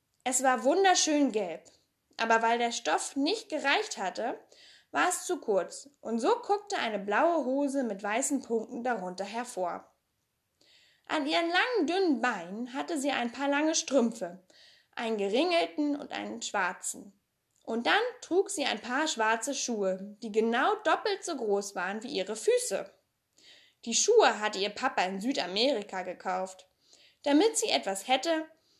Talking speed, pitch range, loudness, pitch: 150 wpm, 225-330 Hz, -29 LUFS, 270 Hz